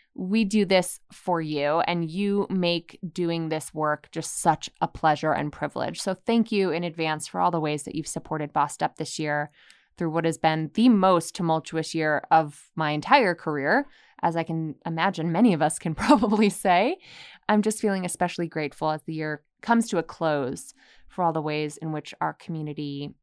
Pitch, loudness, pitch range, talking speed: 165 Hz, -25 LUFS, 155-190 Hz, 195 wpm